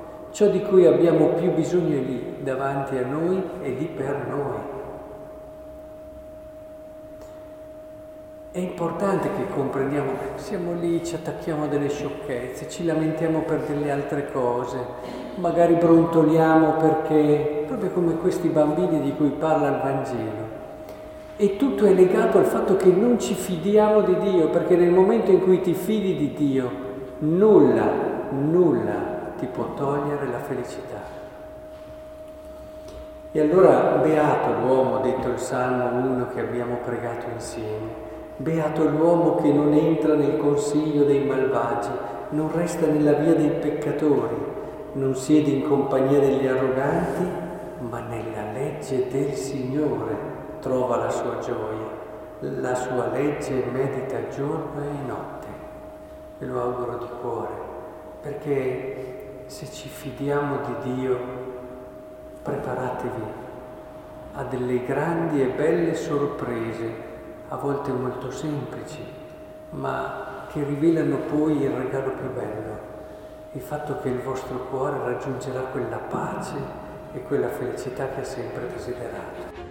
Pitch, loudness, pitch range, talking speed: 150 Hz, -23 LUFS, 130-170 Hz, 125 wpm